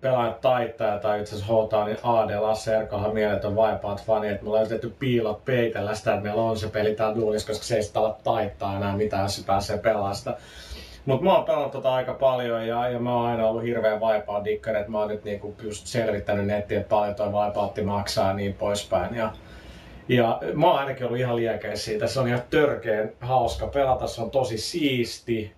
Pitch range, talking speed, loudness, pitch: 105-115 Hz, 200 wpm, -25 LUFS, 110 Hz